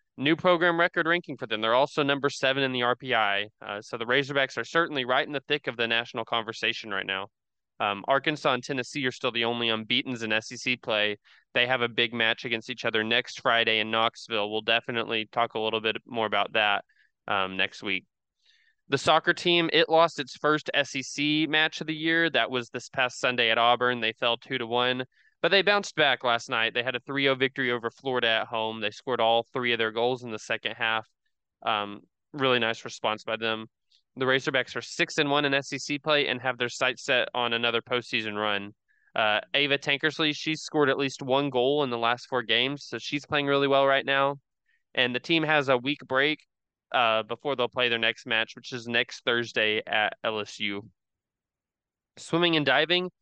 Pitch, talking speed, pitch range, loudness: 125 Hz, 205 wpm, 115-140 Hz, -26 LUFS